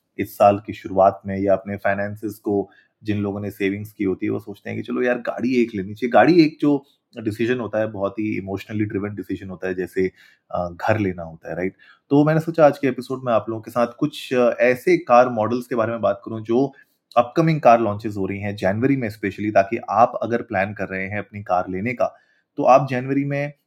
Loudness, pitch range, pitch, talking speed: -21 LUFS, 100-125 Hz, 110 Hz, 230 wpm